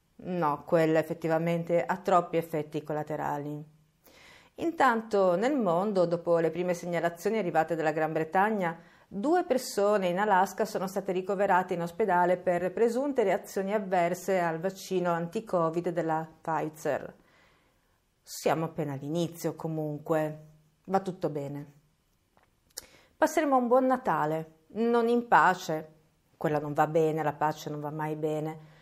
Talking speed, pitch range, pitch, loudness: 125 wpm, 155-195 Hz, 170 Hz, -29 LUFS